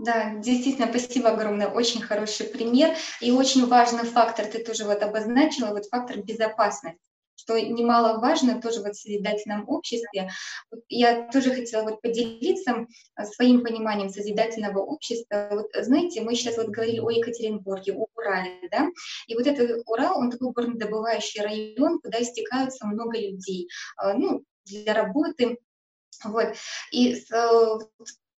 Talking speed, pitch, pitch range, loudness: 130 wpm, 230 Hz, 215-245 Hz, -25 LUFS